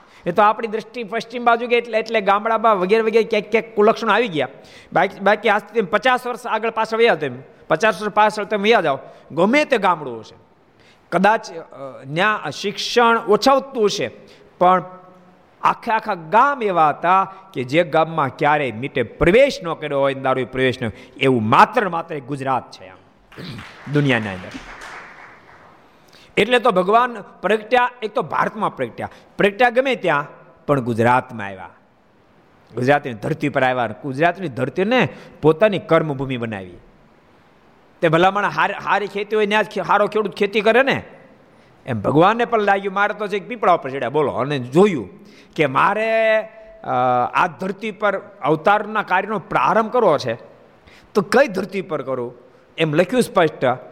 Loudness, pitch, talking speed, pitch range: -18 LUFS, 200 Hz, 150 wpm, 145-220 Hz